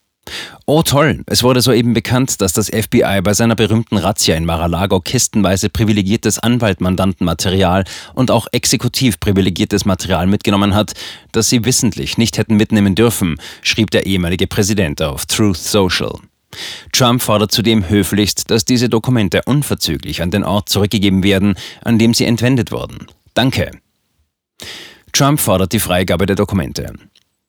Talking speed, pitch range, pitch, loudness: 140 wpm, 95-115 Hz, 105 Hz, -14 LUFS